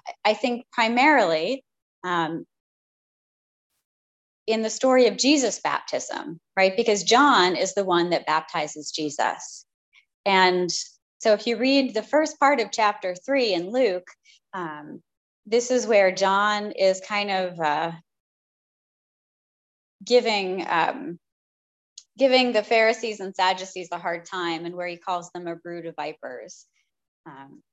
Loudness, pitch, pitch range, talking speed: -23 LUFS, 190 Hz, 170-230 Hz, 130 wpm